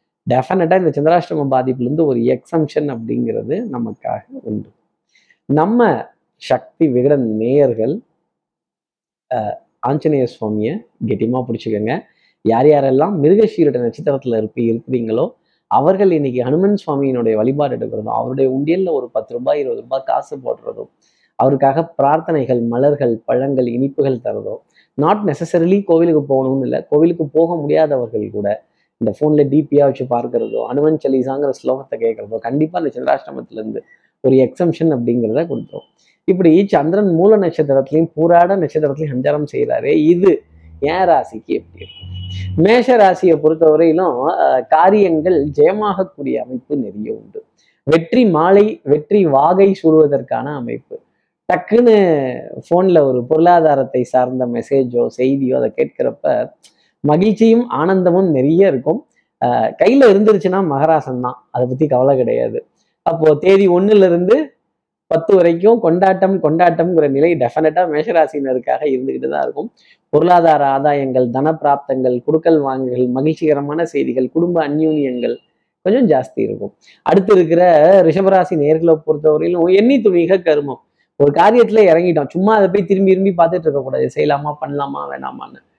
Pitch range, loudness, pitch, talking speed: 135-180 Hz, -14 LUFS, 155 Hz, 110 wpm